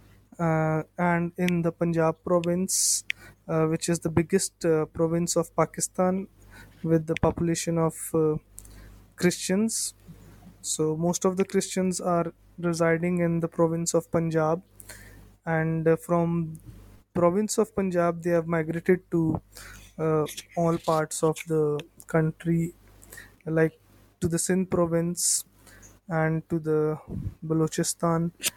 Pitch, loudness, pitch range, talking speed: 165 Hz, -26 LUFS, 155-170 Hz, 120 wpm